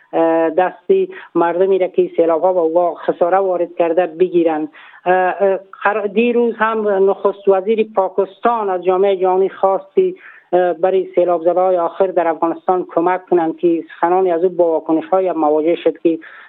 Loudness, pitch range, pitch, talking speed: -16 LUFS, 170-195 Hz, 185 Hz, 135 wpm